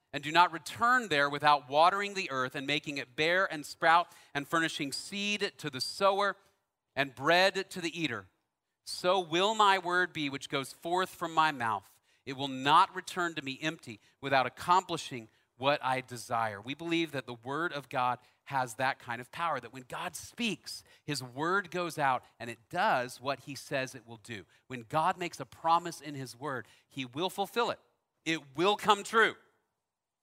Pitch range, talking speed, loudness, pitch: 130-180 Hz, 185 wpm, -31 LUFS, 150 Hz